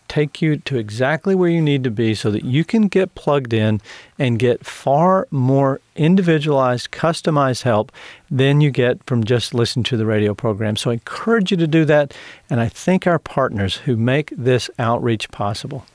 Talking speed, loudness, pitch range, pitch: 190 wpm, -18 LUFS, 115-155 Hz, 130 Hz